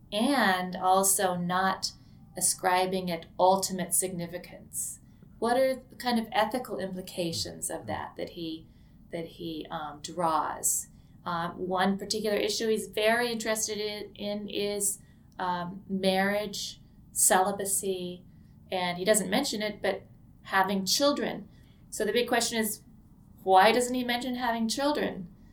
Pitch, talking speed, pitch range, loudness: 195 Hz, 125 wpm, 180-215 Hz, -28 LUFS